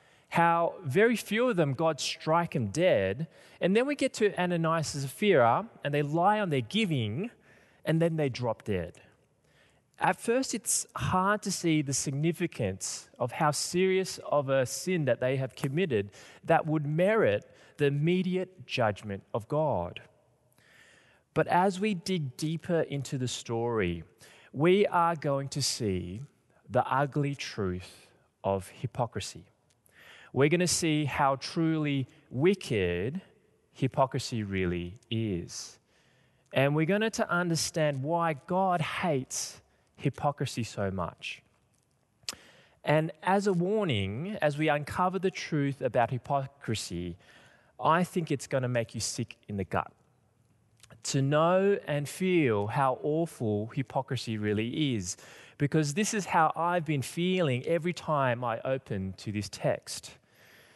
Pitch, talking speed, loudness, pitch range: 145 Hz, 135 wpm, -29 LUFS, 120-175 Hz